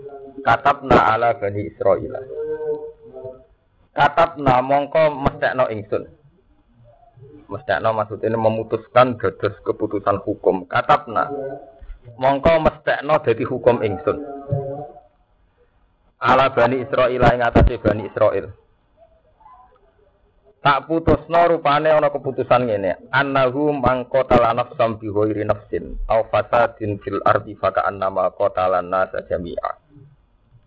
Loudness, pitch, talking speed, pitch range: -19 LUFS, 135 Hz, 85 wpm, 110-145 Hz